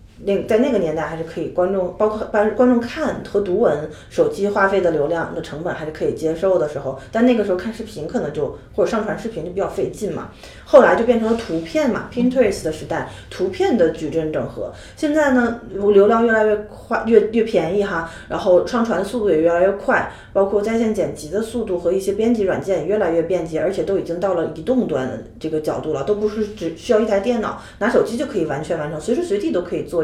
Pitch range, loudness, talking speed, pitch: 175-230 Hz, -19 LUFS, 365 characters per minute, 205 Hz